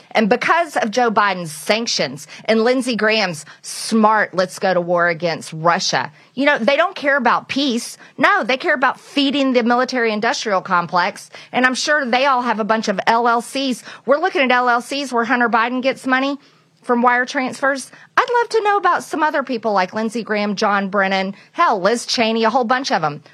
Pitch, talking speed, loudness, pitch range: 235 Hz, 195 wpm, -17 LUFS, 205-270 Hz